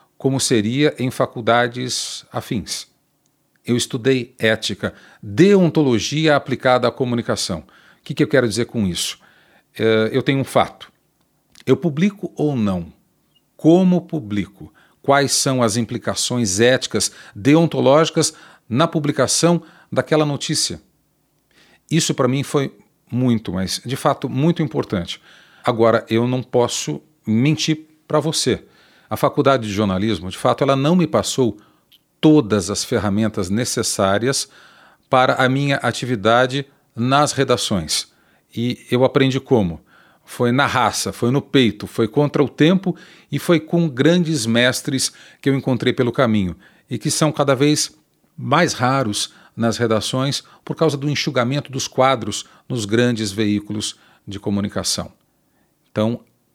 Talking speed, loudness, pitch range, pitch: 130 wpm, -18 LUFS, 115-150 Hz, 130 Hz